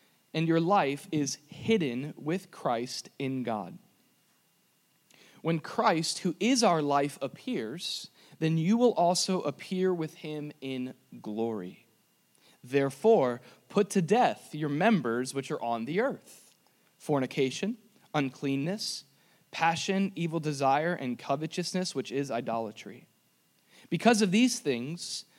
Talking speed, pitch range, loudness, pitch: 120 wpm, 135-185 Hz, -30 LUFS, 155 Hz